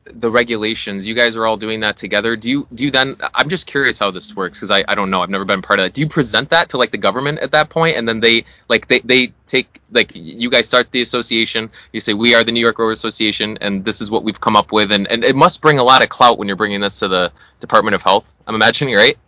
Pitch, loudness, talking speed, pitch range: 115 Hz, -14 LUFS, 290 wpm, 105-125 Hz